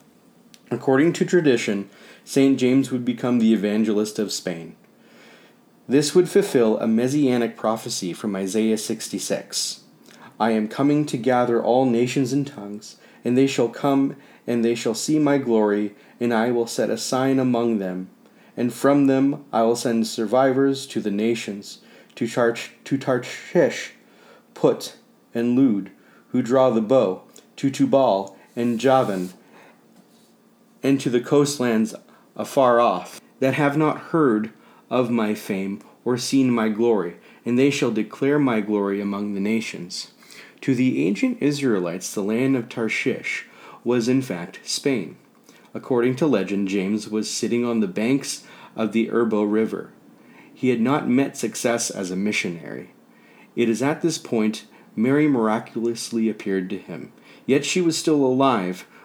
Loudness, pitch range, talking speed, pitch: -22 LUFS, 110-135 Hz, 150 wpm, 120 Hz